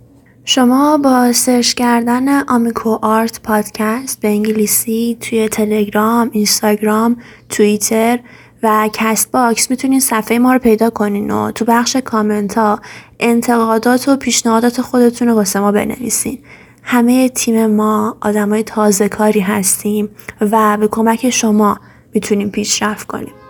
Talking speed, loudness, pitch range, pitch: 125 wpm, -13 LUFS, 215-240 Hz, 225 Hz